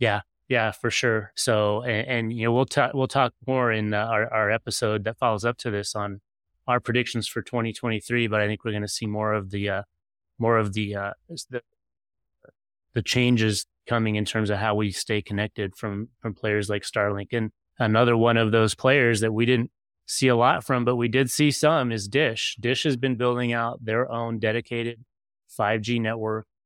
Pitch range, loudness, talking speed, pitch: 105-120 Hz, -24 LUFS, 210 wpm, 115 Hz